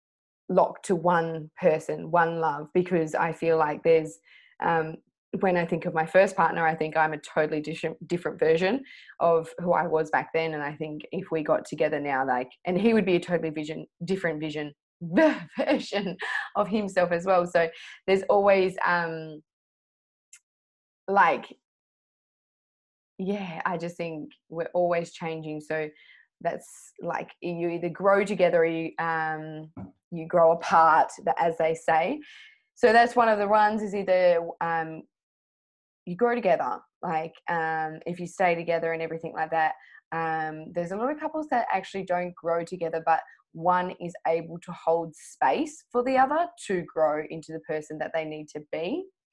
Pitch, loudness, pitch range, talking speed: 170 Hz, -26 LUFS, 160-185 Hz, 165 wpm